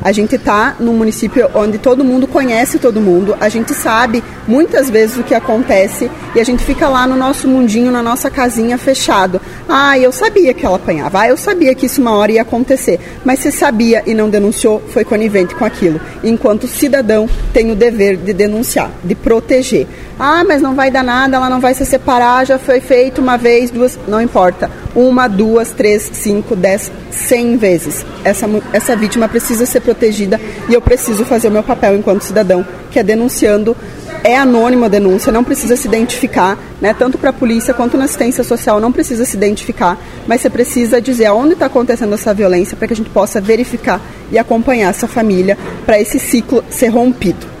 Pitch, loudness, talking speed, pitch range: 235 Hz, -11 LUFS, 195 wpm, 215-255 Hz